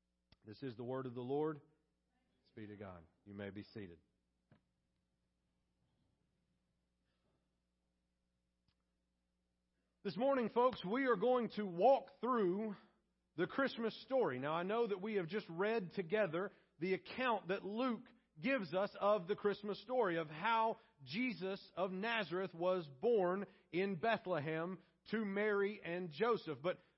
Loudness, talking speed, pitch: -39 LUFS, 130 wpm, 185 Hz